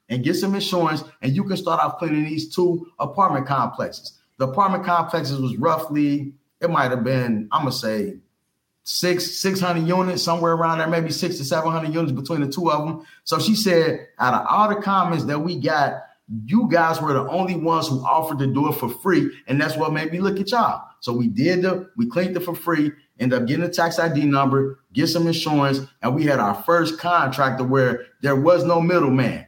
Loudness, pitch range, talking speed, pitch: -21 LUFS, 140-175 Hz, 215 wpm, 160 Hz